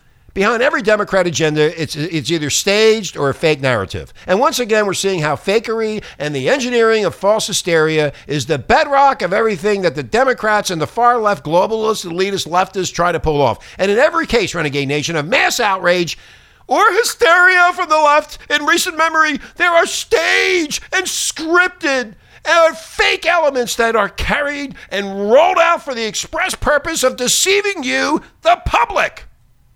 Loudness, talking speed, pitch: -15 LUFS, 165 wpm, 220 Hz